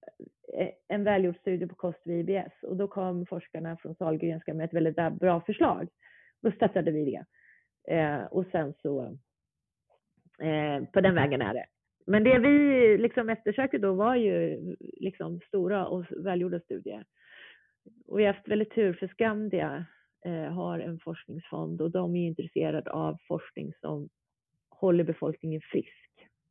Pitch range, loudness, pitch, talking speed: 165-205 Hz, -29 LUFS, 180 Hz, 150 wpm